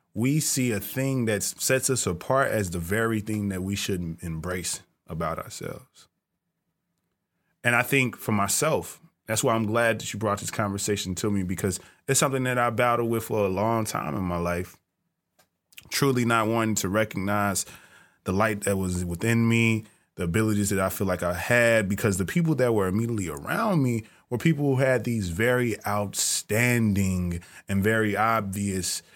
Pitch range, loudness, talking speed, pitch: 95-120 Hz, -25 LUFS, 175 wpm, 110 Hz